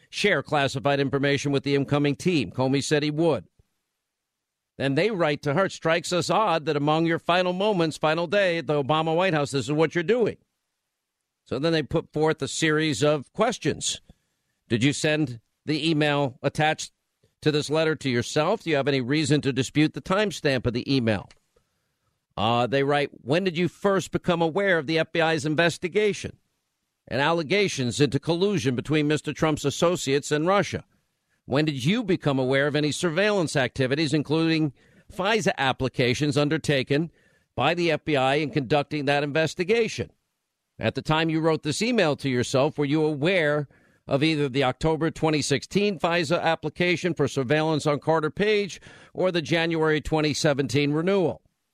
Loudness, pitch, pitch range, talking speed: -24 LUFS, 155 Hz, 140-165 Hz, 165 wpm